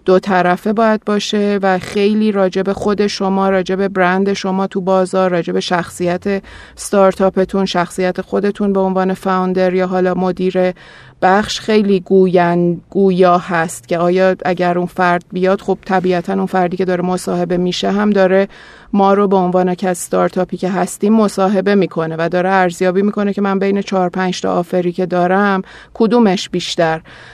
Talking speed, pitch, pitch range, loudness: 155 wpm, 185 Hz, 180-195 Hz, -15 LUFS